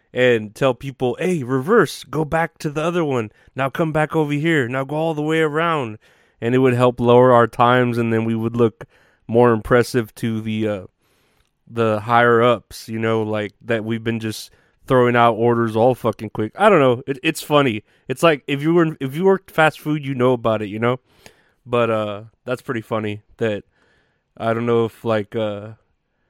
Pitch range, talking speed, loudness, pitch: 110-140 Hz, 200 wpm, -19 LUFS, 120 Hz